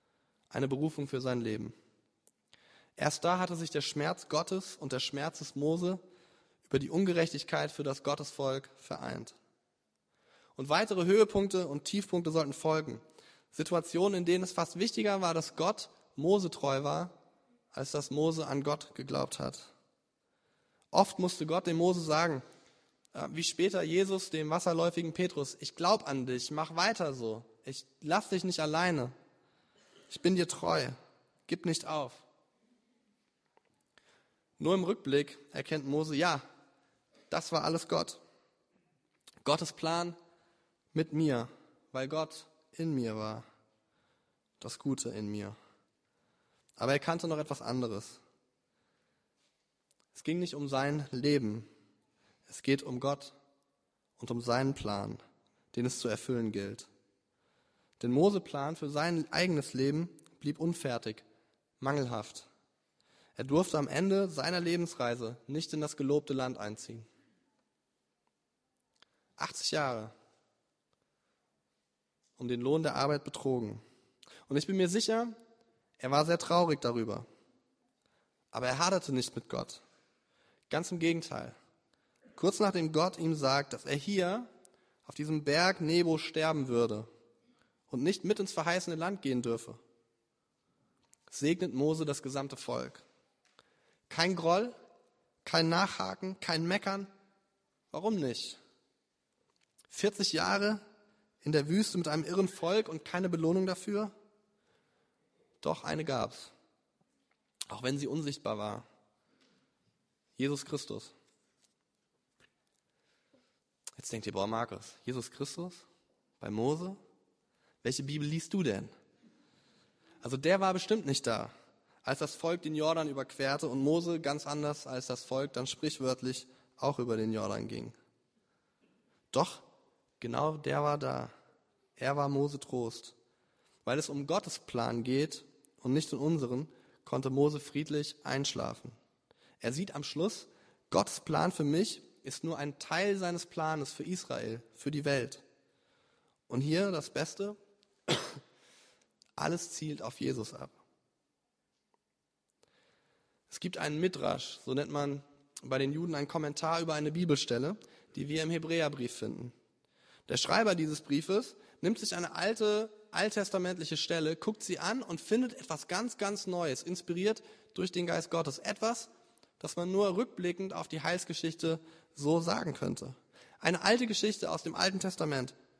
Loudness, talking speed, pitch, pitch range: -34 LUFS, 135 wpm, 155 Hz, 135-180 Hz